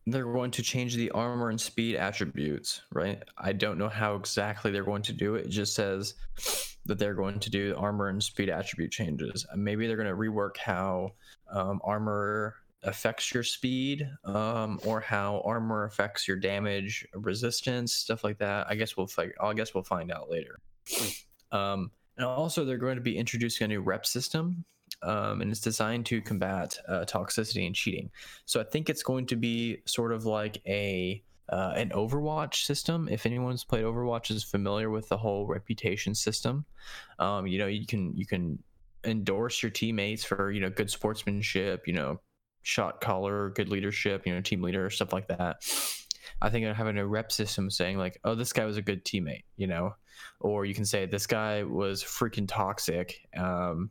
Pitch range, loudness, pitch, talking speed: 100-115 Hz, -31 LUFS, 105 Hz, 190 wpm